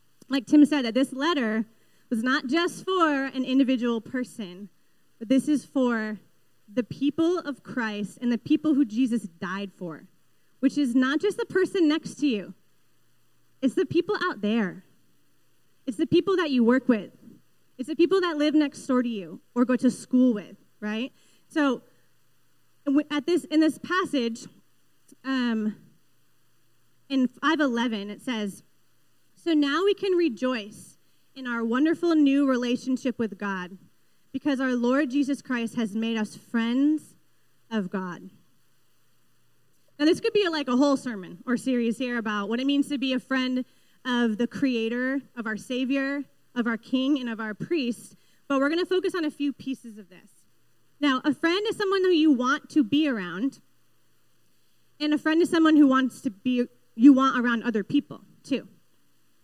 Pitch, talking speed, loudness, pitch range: 255 Hz, 170 wpm, -25 LUFS, 225-295 Hz